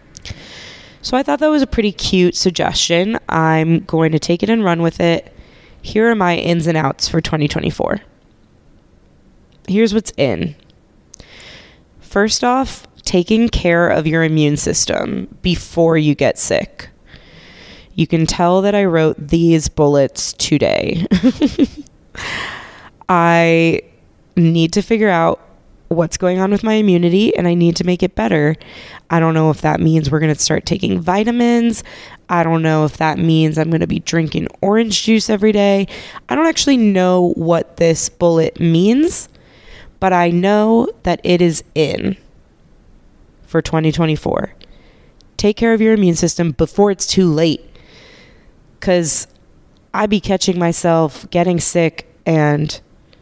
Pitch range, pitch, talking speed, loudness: 160-205 Hz, 175 Hz, 145 wpm, -15 LUFS